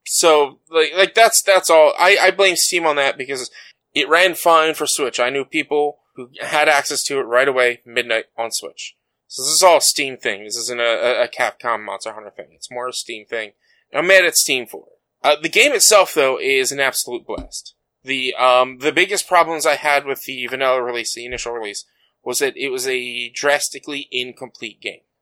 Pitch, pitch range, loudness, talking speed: 145 Hz, 125-180 Hz, -16 LUFS, 210 wpm